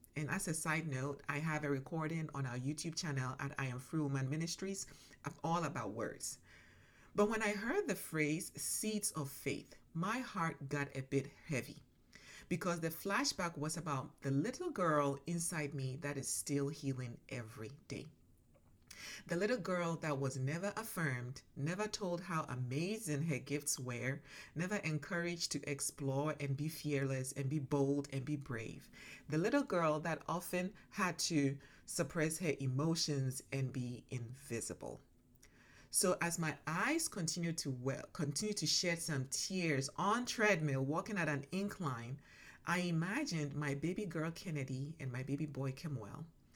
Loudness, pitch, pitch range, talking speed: -39 LUFS, 150 Hz, 140-170 Hz, 160 wpm